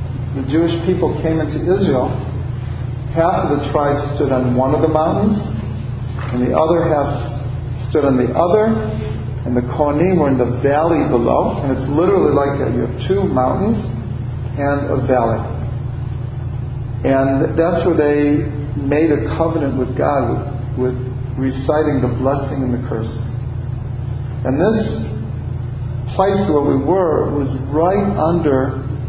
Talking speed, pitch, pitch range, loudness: 140 wpm, 130 Hz, 125-145 Hz, -17 LUFS